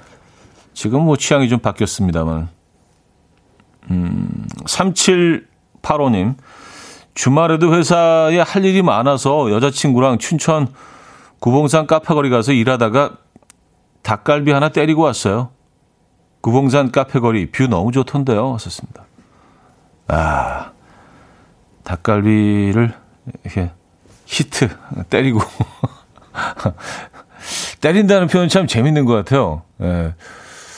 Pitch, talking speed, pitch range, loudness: 130 Hz, 205 characters per minute, 100-150 Hz, -16 LUFS